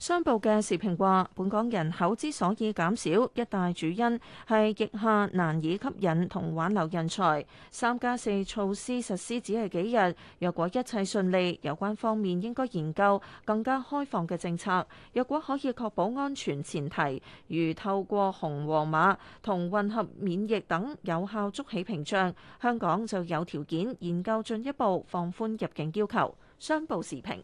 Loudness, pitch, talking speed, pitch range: -30 LUFS, 200 Hz, 245 characters per minute, 175-225 Hz